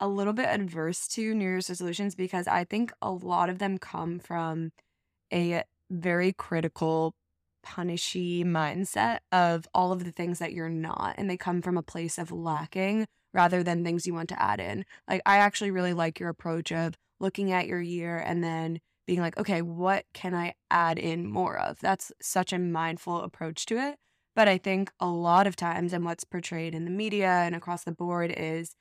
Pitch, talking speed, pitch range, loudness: 175 Hz, 200 wpm, 165-185 Hz, -29 LUFS